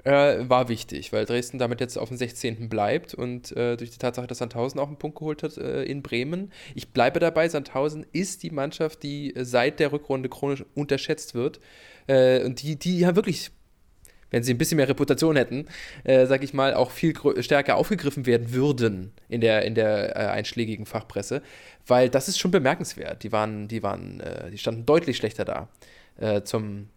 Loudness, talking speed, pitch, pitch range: -25 LUFS, 195 wpm, 130 Hz, 120-150 Hz